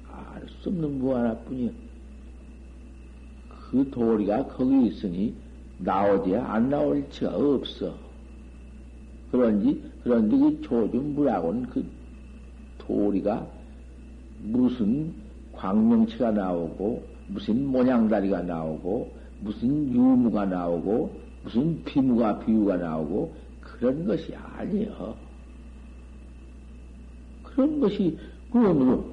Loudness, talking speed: -25 LUFS, 200 characters per minute